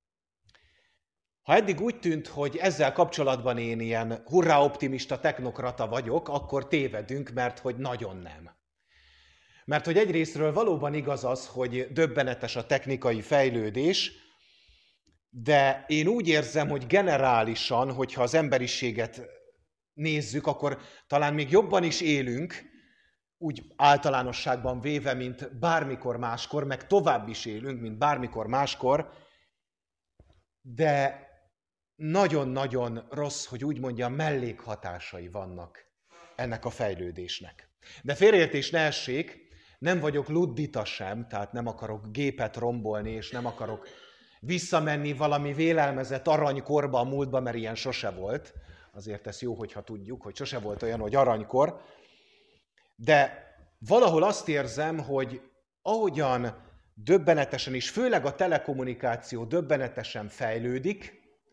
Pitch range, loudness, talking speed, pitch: 120-150 Hz, -28 LUFS, 115 wpm, 135 Hz